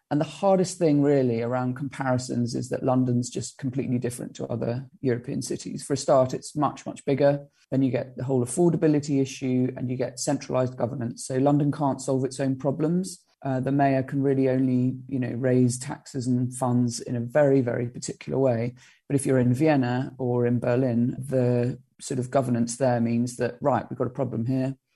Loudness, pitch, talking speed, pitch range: -25 LUFS, 130 Hz, 195 wpm, 125-140 Hz